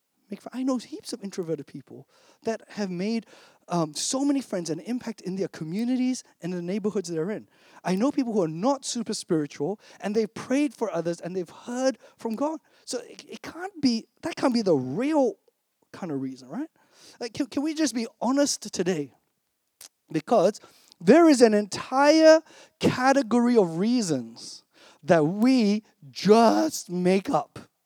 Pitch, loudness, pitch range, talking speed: 225 Hz, -25 LUFS, 185-270 Hz, 165 wpm